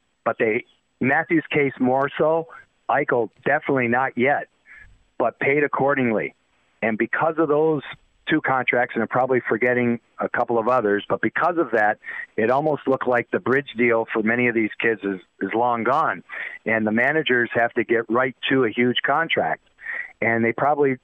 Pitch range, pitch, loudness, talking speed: 115-140 Hz, 125 Hz, -21 LUFS, 175 wpm